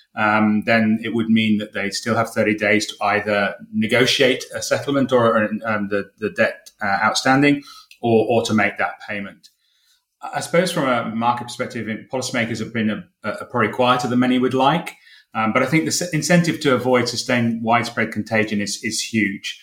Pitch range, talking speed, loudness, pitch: 110-130 Hz, 190 wpm, -19 LUFS, 115 Hz